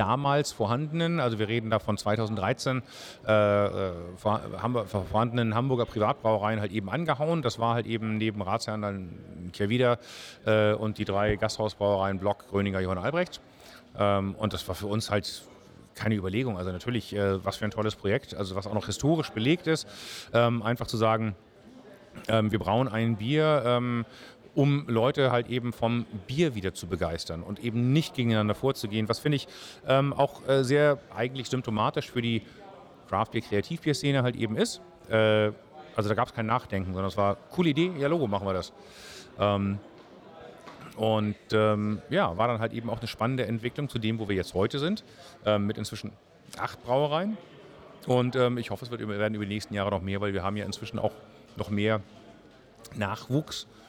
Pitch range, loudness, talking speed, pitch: 105-125 Hz, -28 LUFS, 185 wpm, 110 Hz